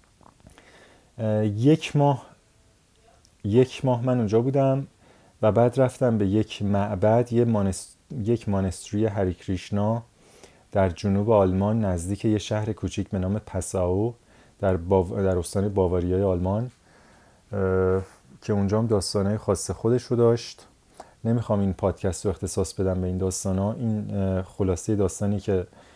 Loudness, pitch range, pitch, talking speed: -25 LUFS, 95-115 Hz, 105 Hz, 130 wpm